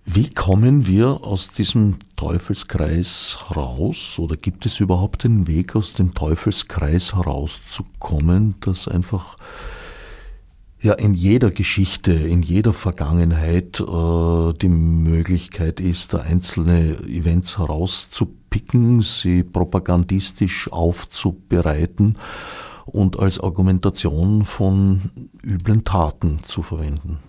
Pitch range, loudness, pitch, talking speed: 85-100 Hz, -19 LUFS, 90 Hz, 100 wpm